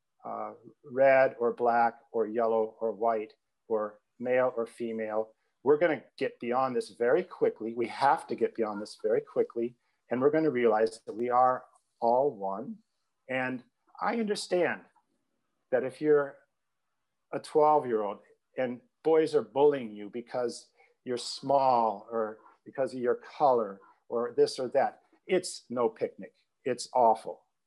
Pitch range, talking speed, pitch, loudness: 115-160 Hz, 150 wpm, 125 Hz, -29 LUFS